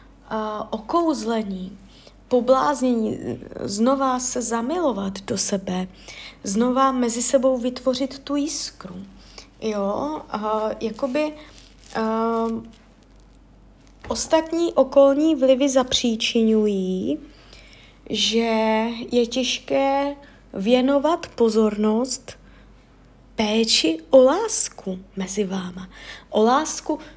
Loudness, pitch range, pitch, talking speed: -21 LUFS, 215-275 Hz, 235 Hz, 75 wpm